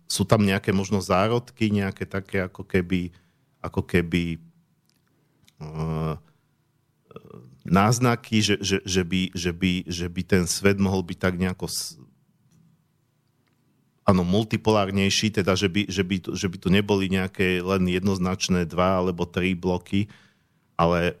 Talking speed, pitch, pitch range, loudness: 130 wpm, 95 Hz, 90-110 Hz, -24 LUFS